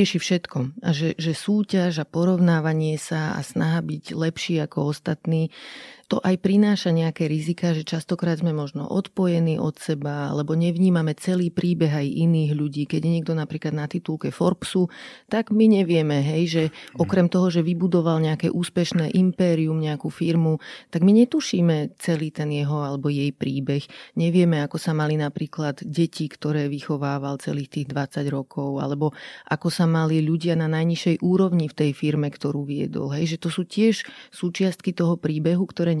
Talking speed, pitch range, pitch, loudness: 160 wpm, 150-175 Hz, 165 Hz, -23 LUFS